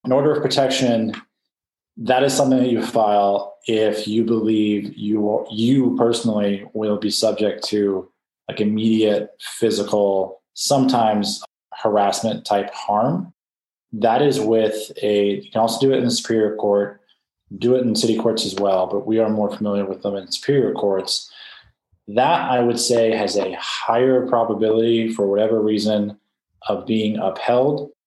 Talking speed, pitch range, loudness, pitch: 155 wpm, 105-115 Hz, -19 LUFS, 110 Hz